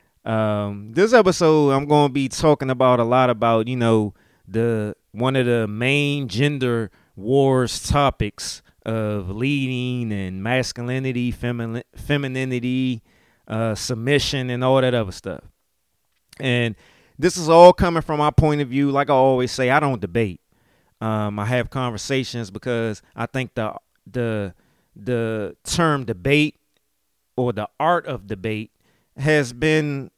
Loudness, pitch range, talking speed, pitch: -20 LUFS, 110-140 Hz, 135 wpm, 125 Hz